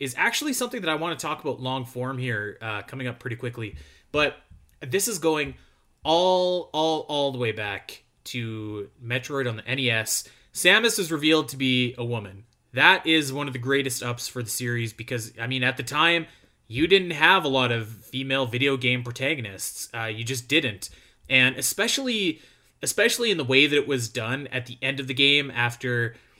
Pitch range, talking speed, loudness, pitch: 120-155 Hz, 195 wpm, -24 LUFS, 130 Hz